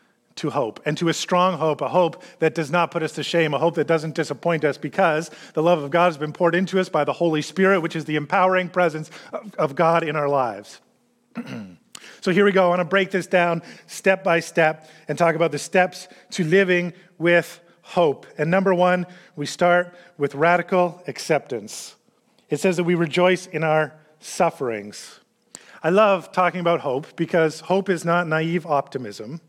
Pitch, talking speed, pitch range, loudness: 170 Hz, 195 wpm, 155-180 Hz, -21 LUFS